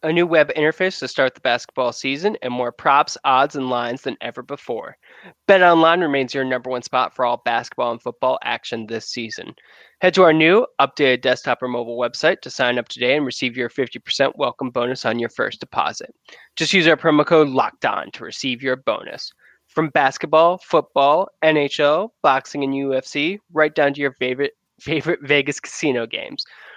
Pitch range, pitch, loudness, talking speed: 125-160 Hz, 140 Hz, -19 LUFS, 185 wpm